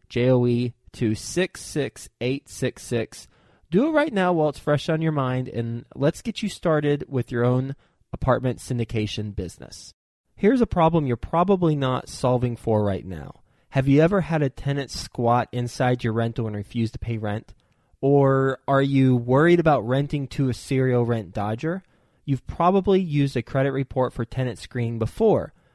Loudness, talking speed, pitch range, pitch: -23 LUFS, 160 wpm, 120-150 Hz, 130 Hz